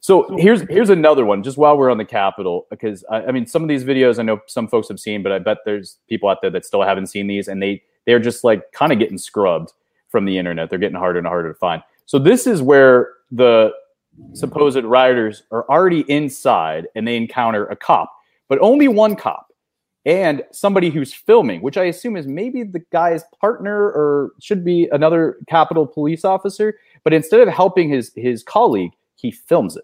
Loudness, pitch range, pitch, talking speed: -16 LUFS, 115-185 Hz, 145 Hz, 205 wpm